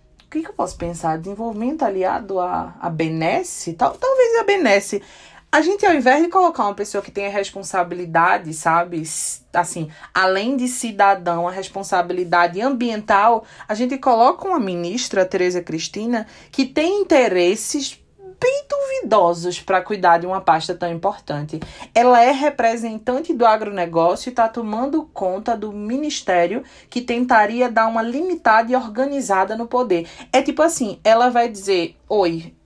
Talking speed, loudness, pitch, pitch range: 145 wpm, -19 LUFS, 215 Hz, 180-260 Hz